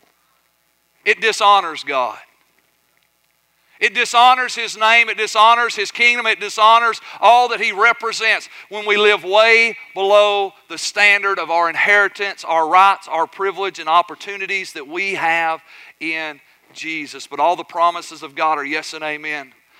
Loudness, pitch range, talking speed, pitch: -15 LUFS, 165-220 Hz, 145 wpm, 200 Hz